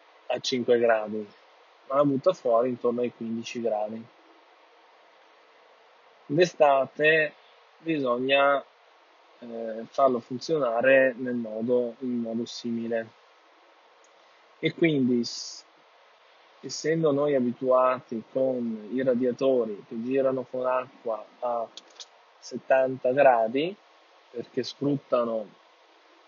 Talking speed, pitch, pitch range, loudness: 85 wpm, 125 Hz, 115-135 Hz, -26 LUFS